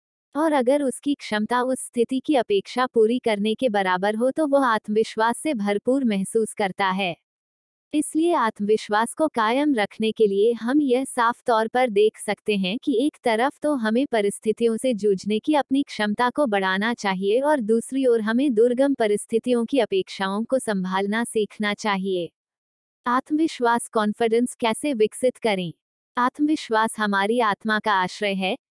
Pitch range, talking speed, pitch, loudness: 210-255 Hz, 150 wpm, 225 Hz, -22 LUFS